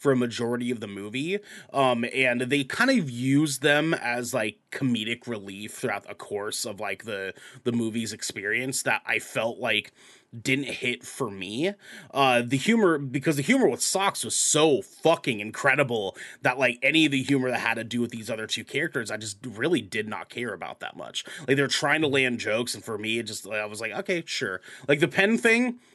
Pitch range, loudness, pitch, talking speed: 115-145 Hz, -26 LUFS, 130 Hz, 210 wpm